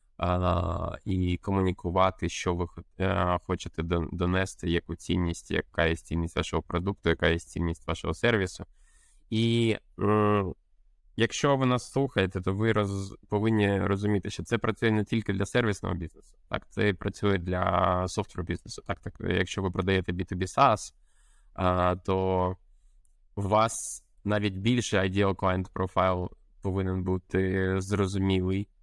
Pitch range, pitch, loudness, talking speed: 90-105 Hz, 95 Hz, -28 LUFS, 135 wpm